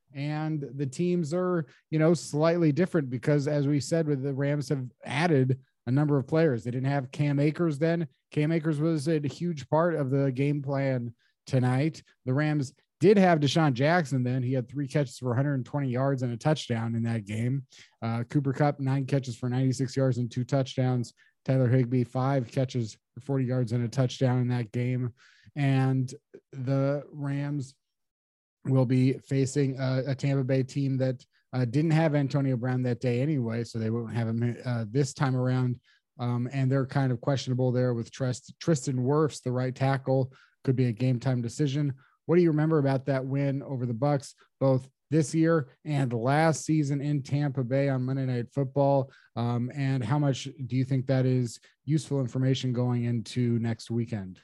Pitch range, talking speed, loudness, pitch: 125-145 Hz, 185 wpm, -28 LUFS, 135 Hz